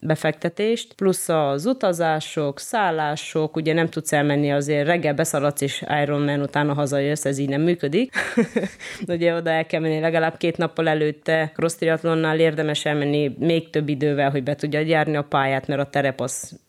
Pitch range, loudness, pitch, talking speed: 145-165 Hz, -22 LUFS, 155 Hz, 165 wpm